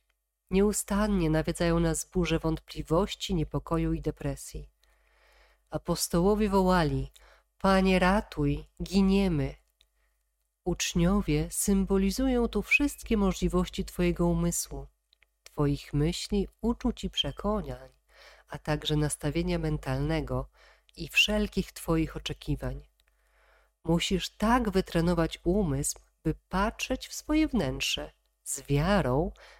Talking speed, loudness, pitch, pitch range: 90 wpm, -29 LUFS, 170 Hz, 150-195 Hz